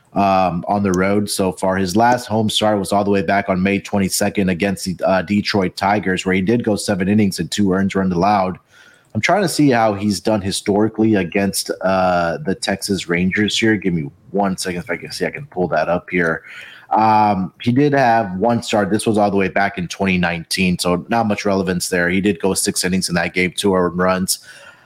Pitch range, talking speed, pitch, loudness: 90-105 Hz, 220 wpm, 100 Hz, -17 LUFS